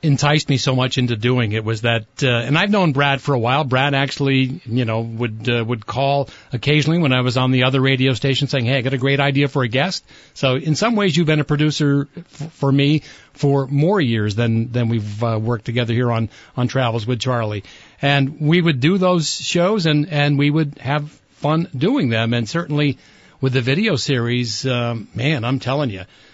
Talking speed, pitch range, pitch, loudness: 215 wpm, 120-145 Hz, 135 Hz, -18 LUFS